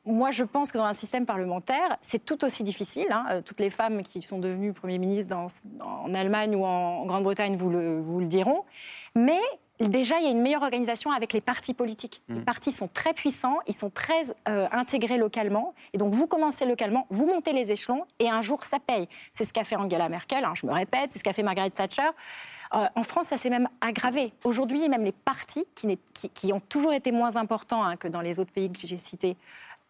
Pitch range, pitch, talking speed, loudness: 195-270 Hz, 230 Hz, 230 wpm, -28 LUFS